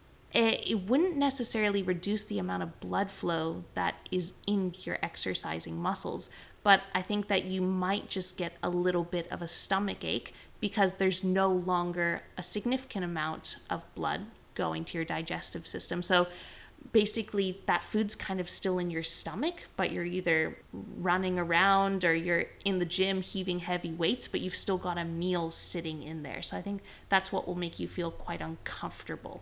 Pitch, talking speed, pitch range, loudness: 185 Hz, 175 wpm, 170-195 Hz, -31 LUFS